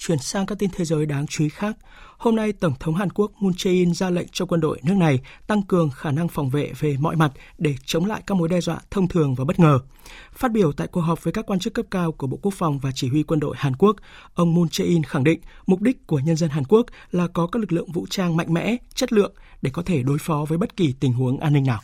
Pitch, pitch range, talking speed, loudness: 170 Hz, 150-195 Hz, 285 wpm, -22 LUFS